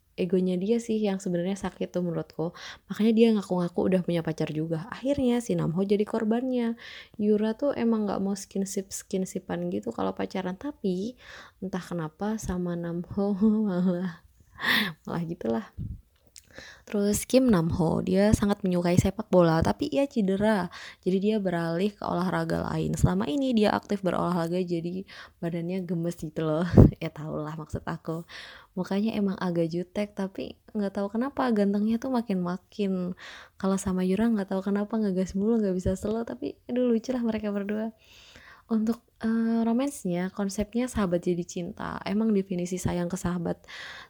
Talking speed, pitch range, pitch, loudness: 150 wpm, 175-215 Hz, 195 Hz, -28 LUFS